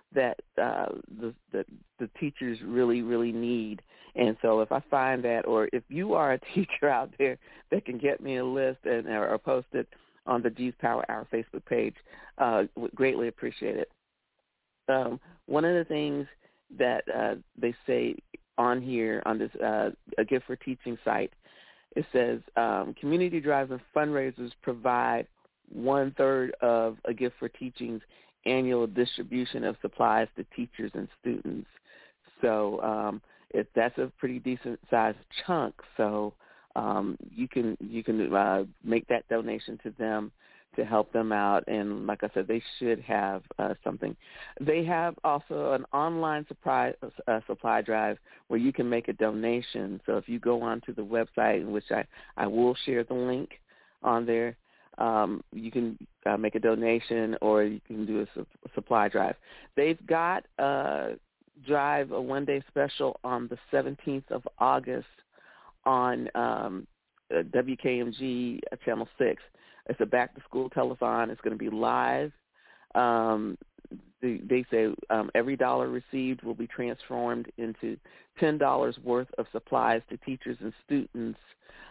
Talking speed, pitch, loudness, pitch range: 155 wpm, 120 Hz, -30 LUFS, 110-130 Hz